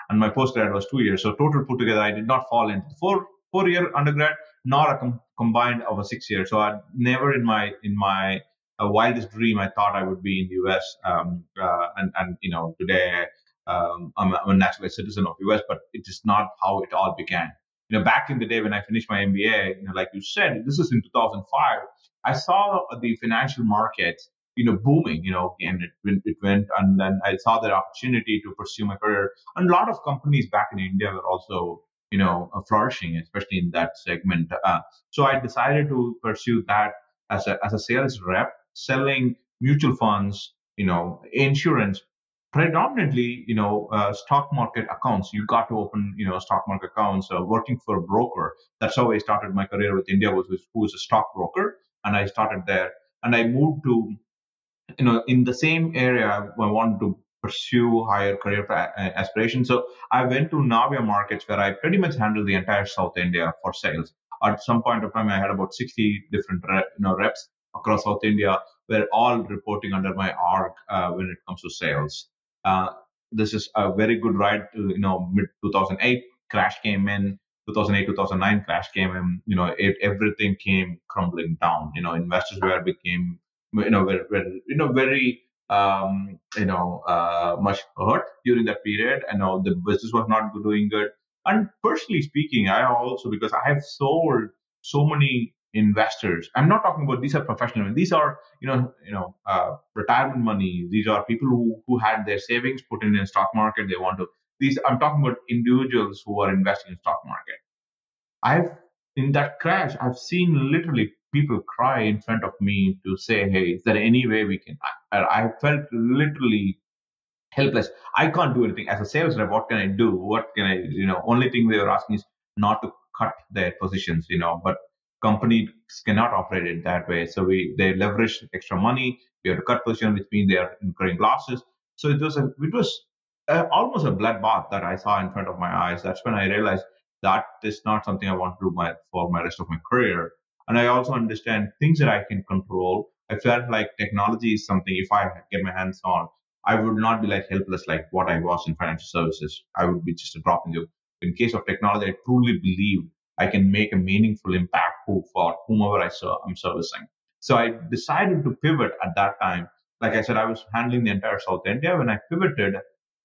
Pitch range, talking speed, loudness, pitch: 95-120 Hz, 210 wpm, -23 LUFS, 105 Hz